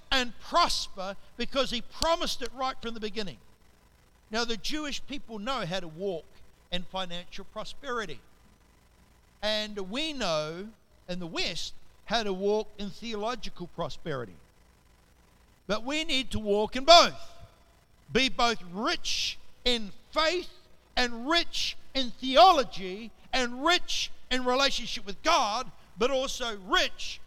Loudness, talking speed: -28 LUFS, 130 wpm